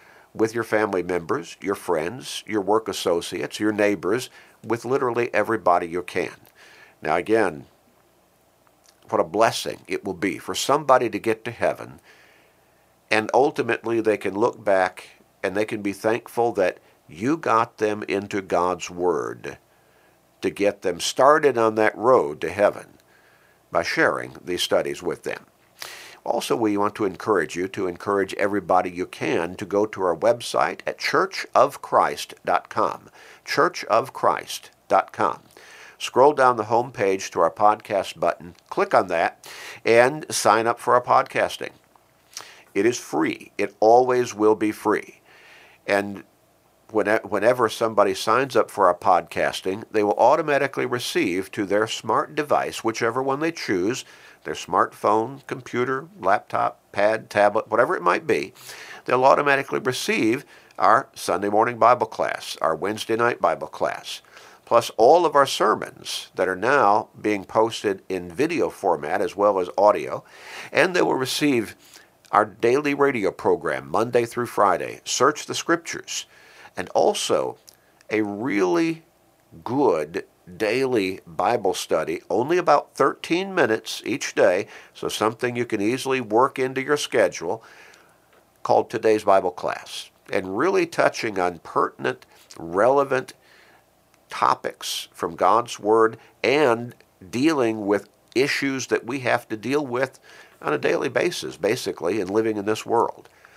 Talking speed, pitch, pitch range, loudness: 140 wpm, 110 Hz, 100-120 Hz, -22 LUFS